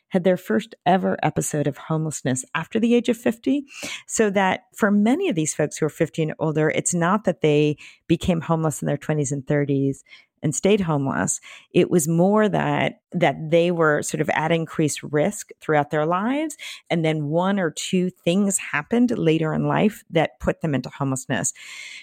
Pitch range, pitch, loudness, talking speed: 150-205 Hz, 165 Hz, -22 LUFS, 185 wpm